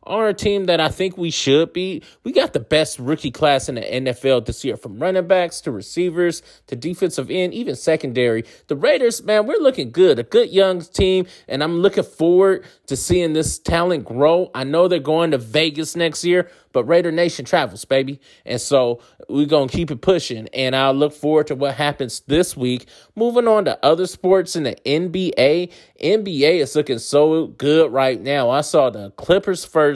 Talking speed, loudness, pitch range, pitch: 200 wpm, -18 LUFS, 135-180 Hz, 160 Hz